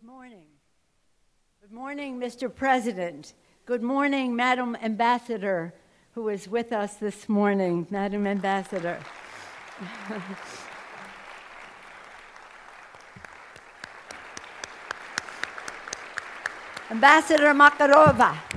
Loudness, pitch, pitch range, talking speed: -23 LUFS, 230 Hz, 200-255 Hz, 65 wpm